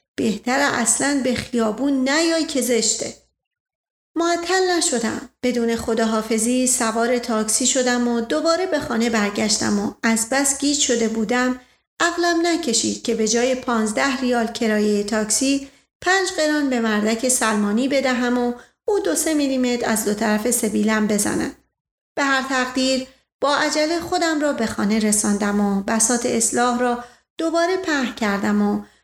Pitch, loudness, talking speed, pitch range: 245 Hz, -20 LUFS, 140 wpm, 225-280 Hz